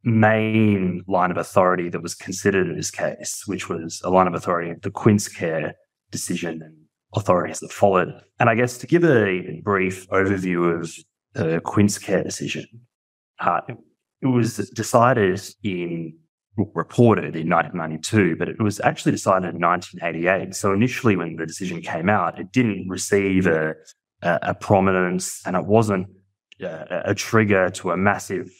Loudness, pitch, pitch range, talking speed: -21 LUFS, 95 Hz, 85-105 Hz, 155 wpm